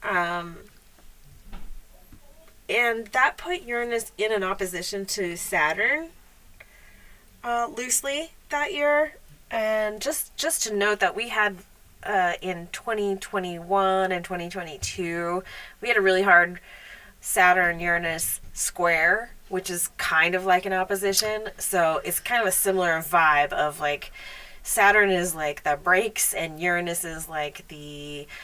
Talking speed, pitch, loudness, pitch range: 135 wpm, 185 Hz, -24 LUFS, 170-215 Hz